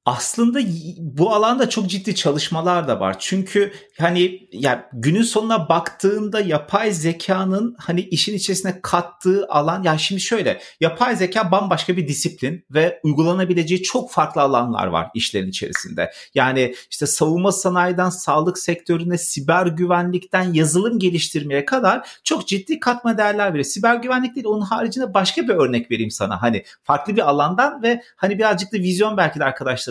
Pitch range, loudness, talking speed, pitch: 155-205 Hz, -19 LUFS, 155 wpm, 180 Hz